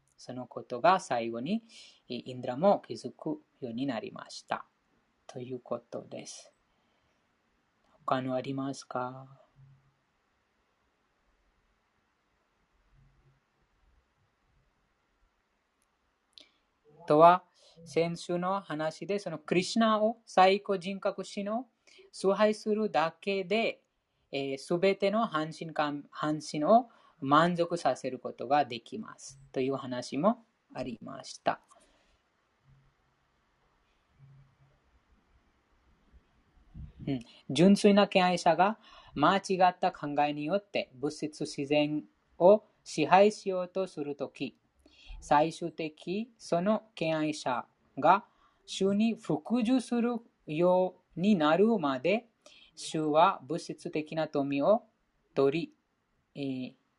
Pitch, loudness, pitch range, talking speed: 160 Hz, -30 LUFS, 135-200 Hz, 170 characters per minute